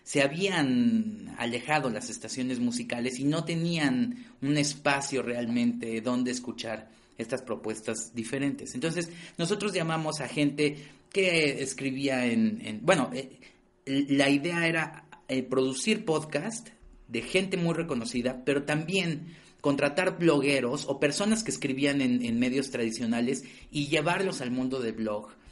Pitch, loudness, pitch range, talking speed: 140 Hz, -29 LUFS, 125-170 Hz, 130 wpm